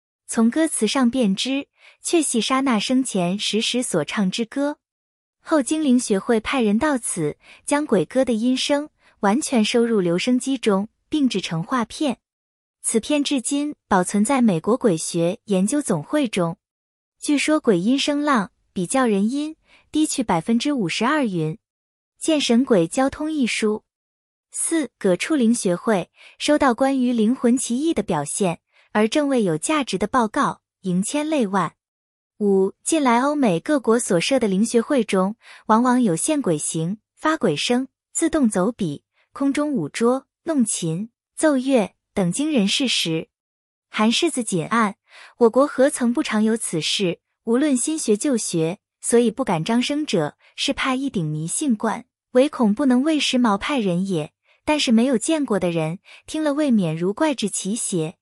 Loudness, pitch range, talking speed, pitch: -21 LUFS, 195-275 Hz, 225 characters per minute, 235 Hz